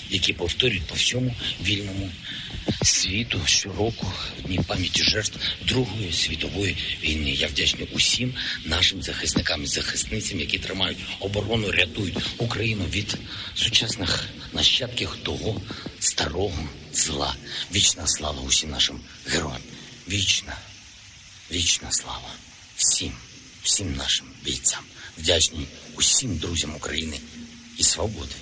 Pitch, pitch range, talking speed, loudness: 95 Hz, 85-105 Hz, 105 wpm, -23 LUFS